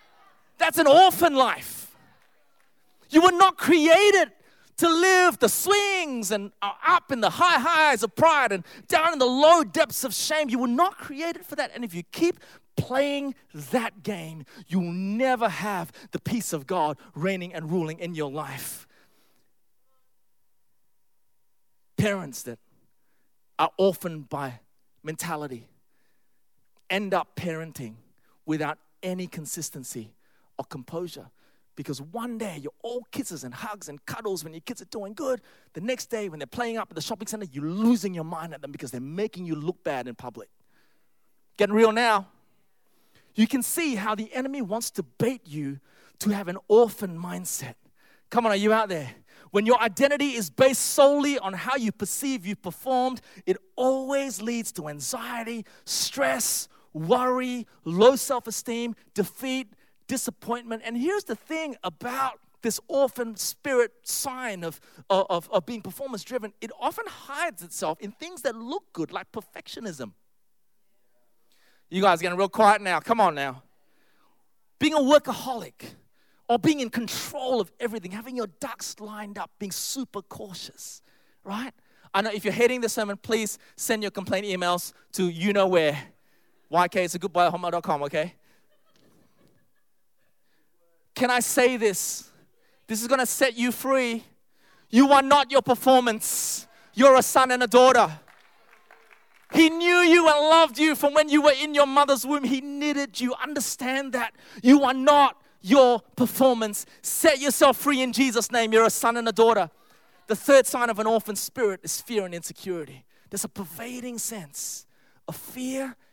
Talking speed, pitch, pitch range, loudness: 160 wpm, 225 Hz, 180-265 Hz, -24 LUFS